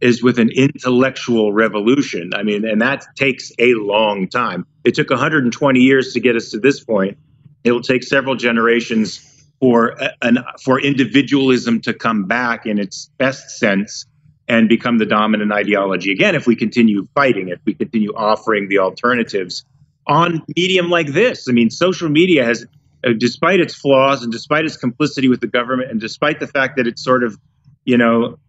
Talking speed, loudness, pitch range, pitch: 180 wpm, -16 LUFS, 115-140 Hz, 125 Hz